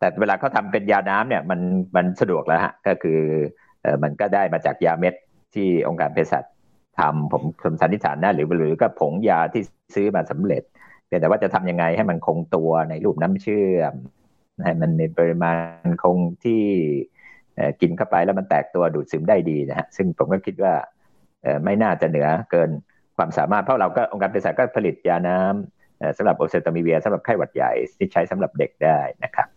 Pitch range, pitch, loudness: 80-90 Hz, 85 Hz, -21 LUFS